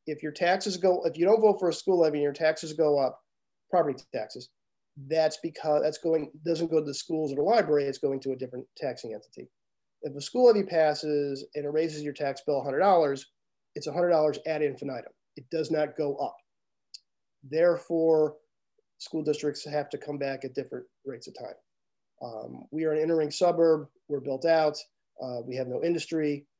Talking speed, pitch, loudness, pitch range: 190 wpm, 155 Hz, -28 LUFS, 145-165 Hz